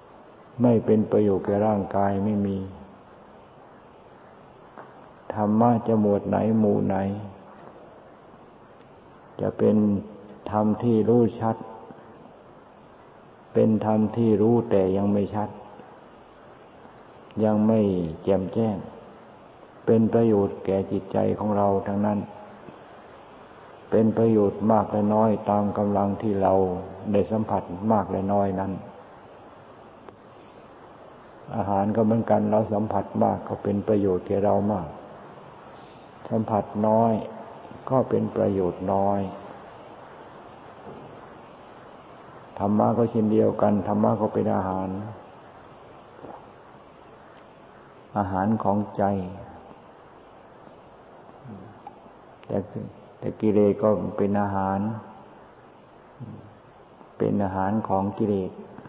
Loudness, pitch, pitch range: -24 LUFS, 105 Hz, 100-110 Hz